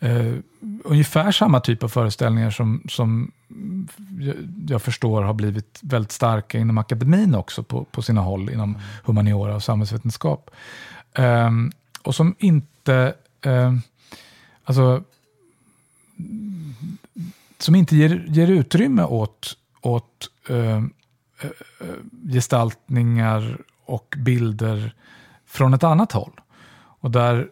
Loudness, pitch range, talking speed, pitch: -20 LUFS, 115-160 Hz, 110 wpm, 125 Hz